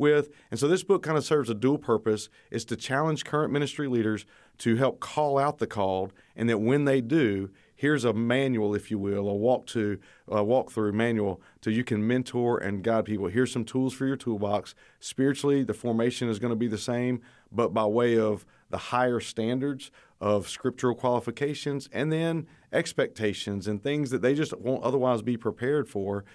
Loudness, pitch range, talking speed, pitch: -28 LUFS, 110-135 Hz, 195 wpm, 120 Hz